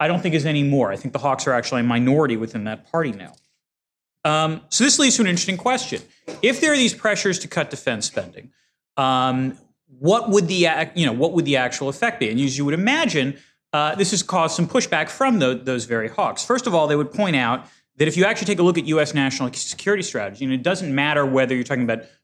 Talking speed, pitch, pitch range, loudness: 245 wpm, 150 Hz, 130-195 Hz, -20 LUFS